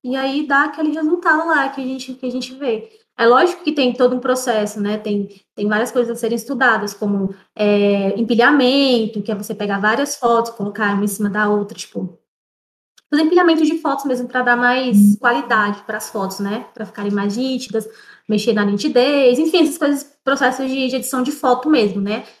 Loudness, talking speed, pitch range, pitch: -17 LUFS, 200 wpm, 210-270 Hz, 245 Hz